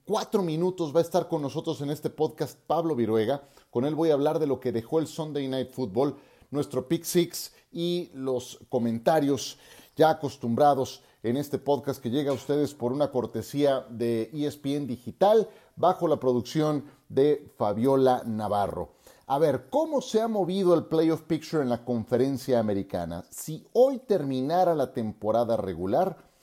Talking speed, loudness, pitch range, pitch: 165 wpm, -27 LUFS, 125-160 Hz, 145 Hz